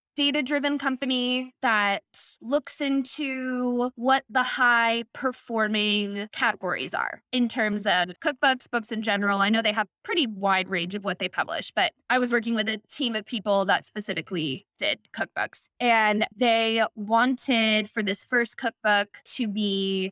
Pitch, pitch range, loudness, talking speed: 230 Hz, 205-255 Hz, -25 LUFS, 155 wpm